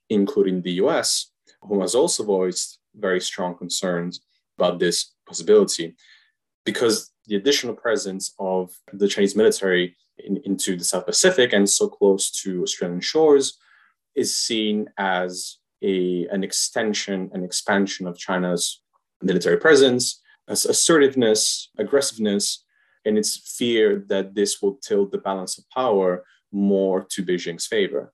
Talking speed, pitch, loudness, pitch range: 130 wpm, 100 Hz, -21 LUFS, 90-130 Hz